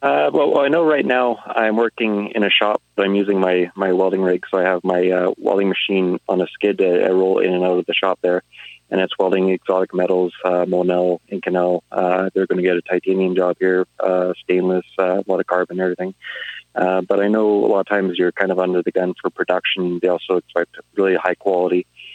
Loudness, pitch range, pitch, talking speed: -18 LUFS, 90-95 Hz, 90 Hz, 235 wpm